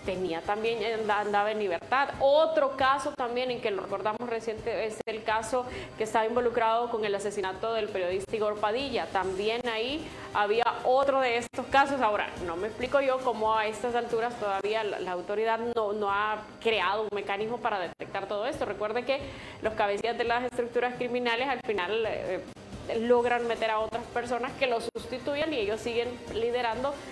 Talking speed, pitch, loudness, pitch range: 175 wpm, 230 Hz, -29 LUFS, 215-245 Hz